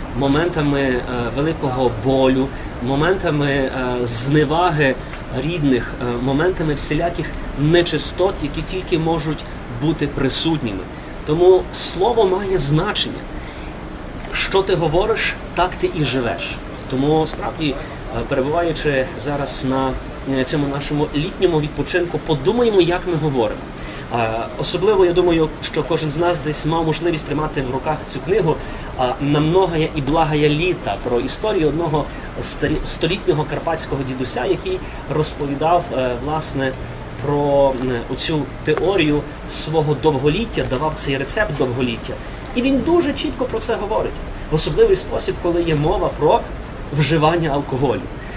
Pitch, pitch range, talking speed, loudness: 150 Hz, 135-170 Hz, 115 wpm, -19 LUFS